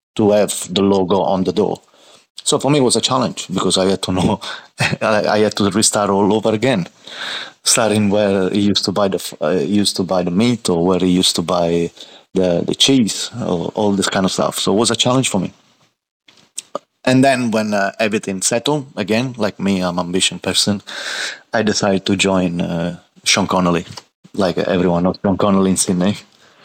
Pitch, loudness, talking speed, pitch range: 100 Hz, -16 LUFS, 200 wpm, 95-105 Hz